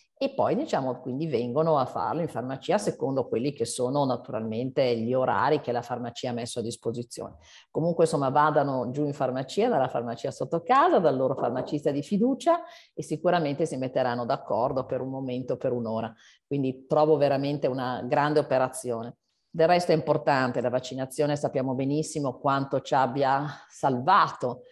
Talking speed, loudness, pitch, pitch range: 160 wpm, -27 LUFS, 135 Hz, 125-155 Hz